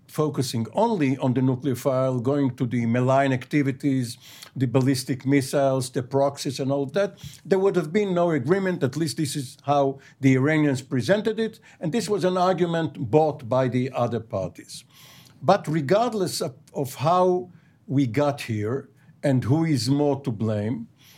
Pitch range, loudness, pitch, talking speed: 130-160 Hz, -24 LUFS, 140 Hz, 160 wpm